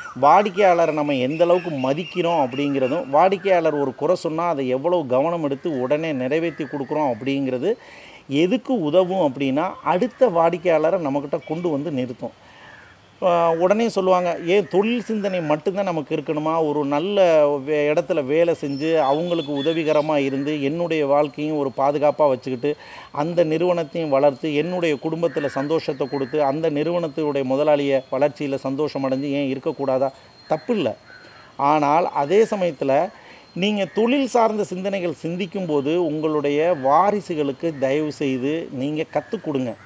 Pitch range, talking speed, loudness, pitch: 145-175 Hz, 120 wpm, -21 LUFS, 155 Hz